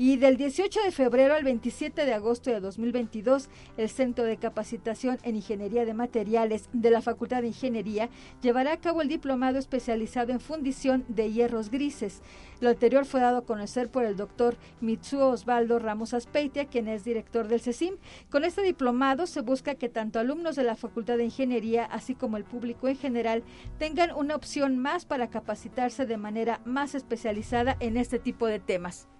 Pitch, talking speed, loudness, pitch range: 245 Hz, 180 wpm, -28 LUFS, 230-270 Hz